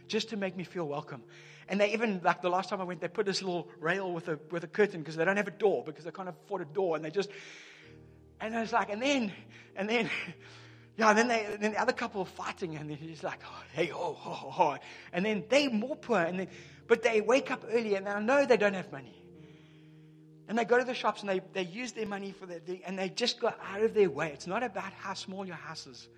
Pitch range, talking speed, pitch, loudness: 170-220 Hz, 275 wpm, 195 Hz, -32 LUFS